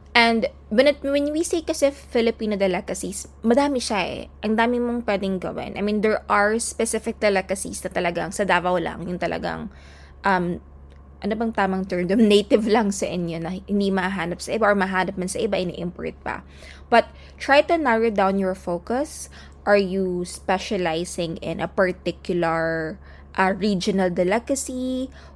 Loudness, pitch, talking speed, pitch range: -22 LUFS, 195 Hz, 155 wpm, 180-230 Hz